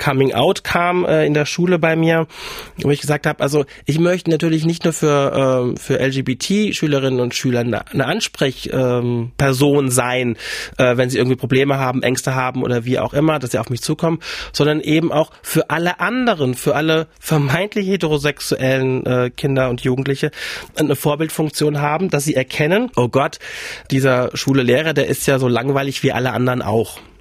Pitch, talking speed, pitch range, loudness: 140 Hz, 170 wpm, 130-155 Hz, -17 LUFS